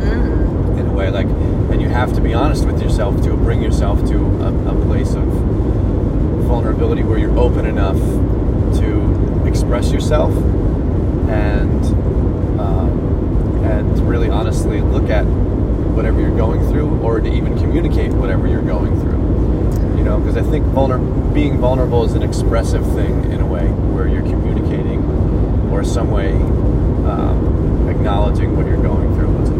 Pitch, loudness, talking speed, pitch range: 95 Hz, -16 LUFS, 150 wpm, 80-100 Hz